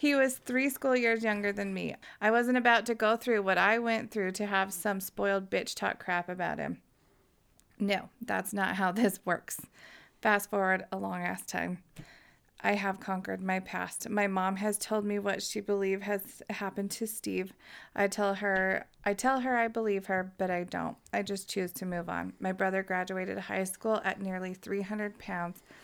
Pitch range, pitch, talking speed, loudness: 190-215 Hz, 200 Hz, 195 wpm, -32 LUFS